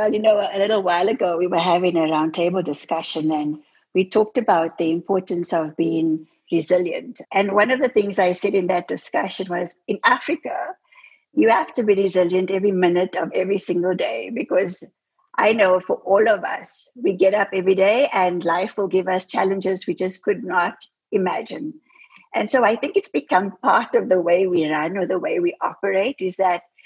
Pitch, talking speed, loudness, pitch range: 185 Hz, 195 wpm, -20 LUFS, 175-210 Hz